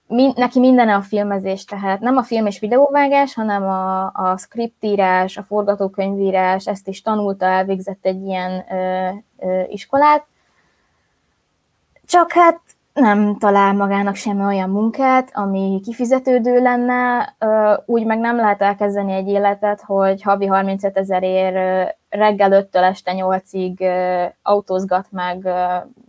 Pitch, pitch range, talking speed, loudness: 200 Hz, 190-230 Hz, 120 wpm, -17 LUFS